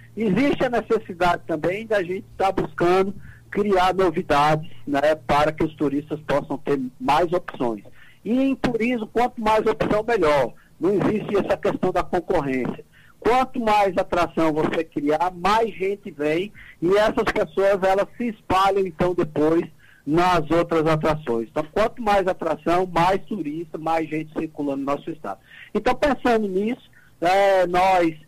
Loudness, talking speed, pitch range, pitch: -22 LUFS, 145 wpm, 155-205 Hz, 180 Hz